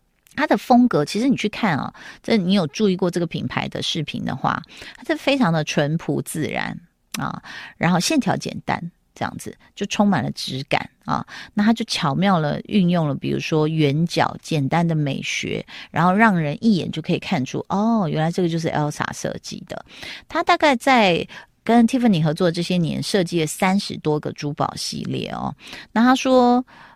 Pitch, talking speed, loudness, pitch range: 185 Hz, 290 characters per minute, -21 LUFS, 160-225 Hz